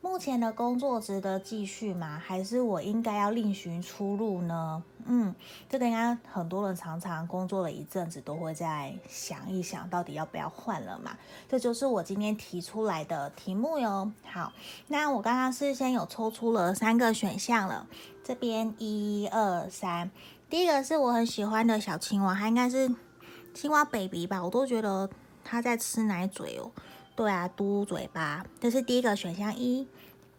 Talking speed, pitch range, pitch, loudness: 255 characters per minute, 185-240 Hz, 210 Hz, -31 LUFS